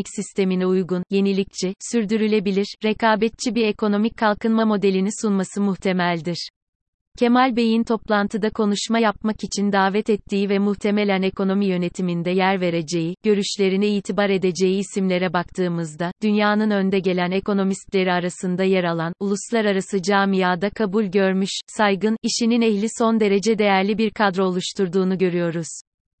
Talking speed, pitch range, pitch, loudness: 115 wpm, 185-215 Hz, 200 Hz, -21 LUFS